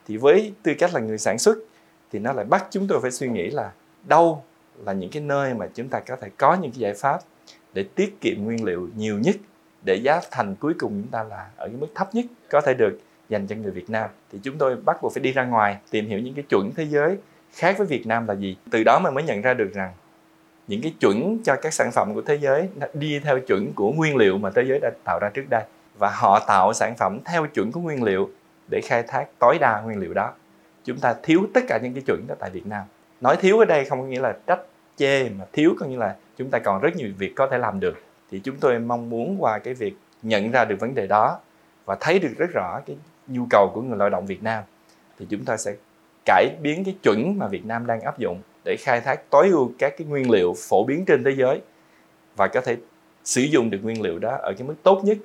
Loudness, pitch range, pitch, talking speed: -22 LUFS, 115-190 Hz, 140 Hz, 260 wpm